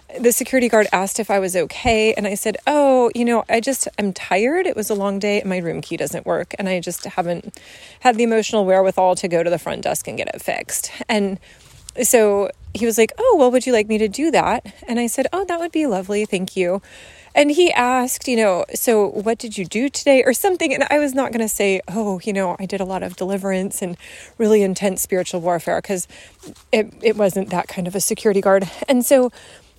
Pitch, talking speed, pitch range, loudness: 215 Hz, 235 wpm, 195-250 Hz, -19 LUFS